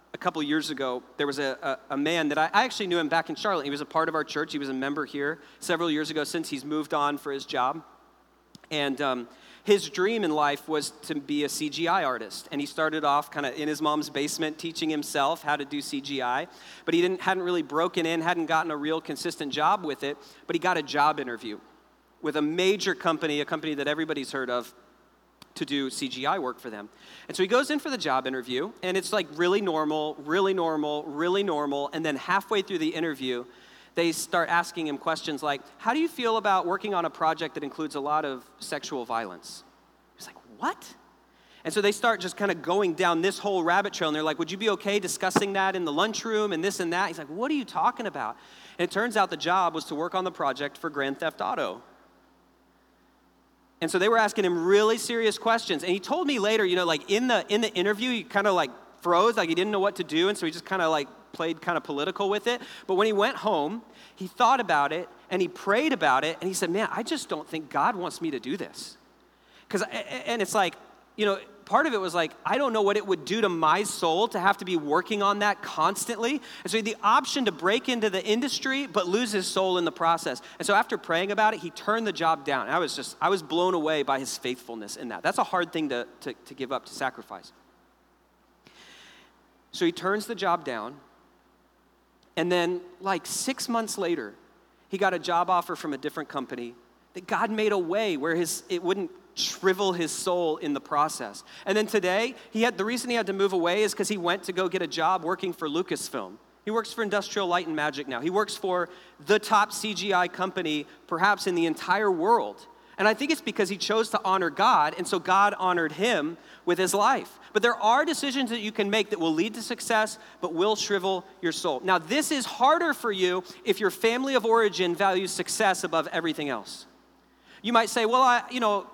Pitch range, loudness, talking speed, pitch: 155-210 Hz, -27 LUFS, 235 wpm, 180 Hz